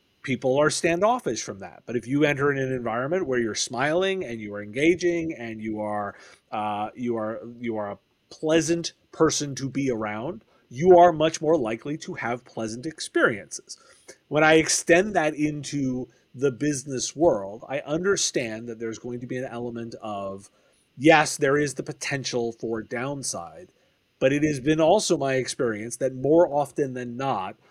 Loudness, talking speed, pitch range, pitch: -24 LUFS, 170 wpm, 115-155 Hz, 135 Hz